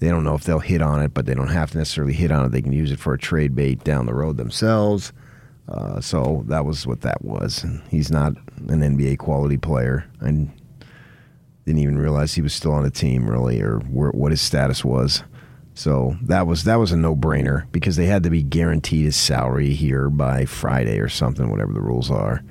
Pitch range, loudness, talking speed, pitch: 70-80 Hz, -20 LUFS, 220 wpm, 75 Hz